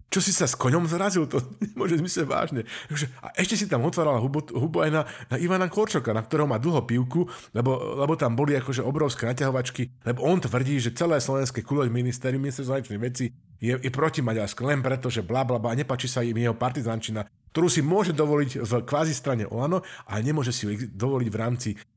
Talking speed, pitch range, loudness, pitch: 210 wpm, 120-155 Hz, -26 LUFS, 135 Hz